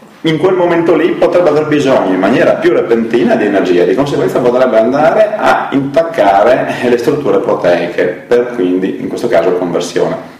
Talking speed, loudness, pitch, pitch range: 165 wpm, -11 LUFS, 140 Hz, 120-170 Hz